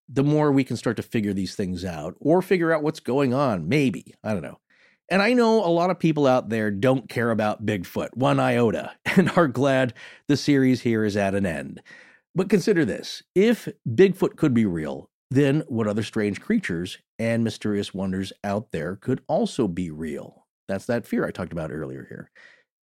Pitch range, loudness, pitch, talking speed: 100-155 Hz, -23 LUFS, 120 Hz, 195 wpm